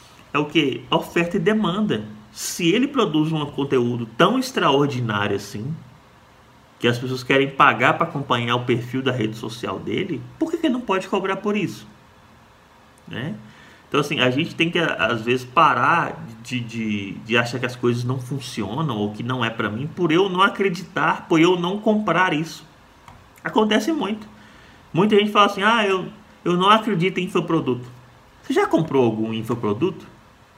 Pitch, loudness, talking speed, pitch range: 150 Hz, -21 LUFS, 175 wpm, 120-195 Hz